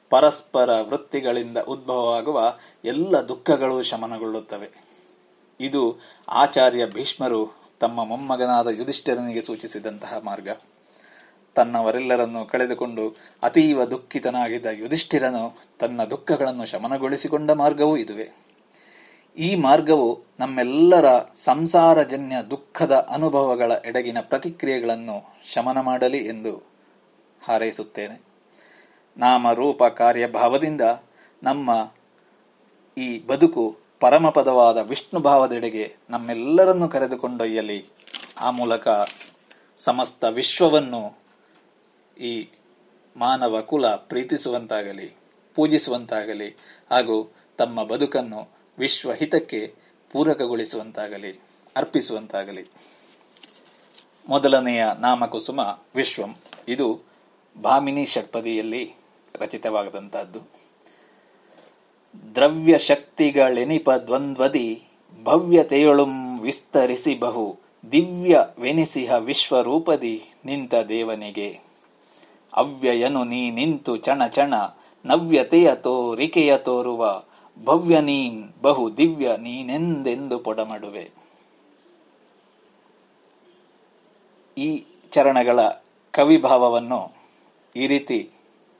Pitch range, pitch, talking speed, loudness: 115-150 Hz, 125 Hz, 65 wpm, -21 LUFS